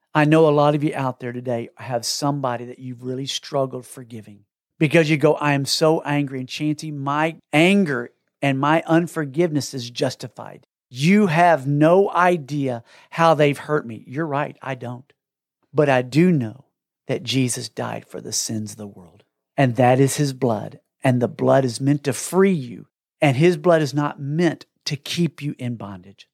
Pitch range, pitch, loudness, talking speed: 125-160 Hz, 140 Hz, -20 LUFS, 185 wpm